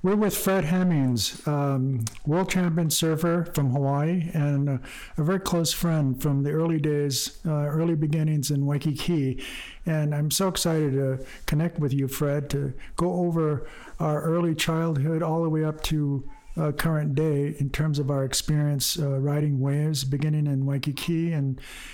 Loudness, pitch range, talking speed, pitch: -25 LUFS, 140-165 Hz, 160 wpm, 150 Hz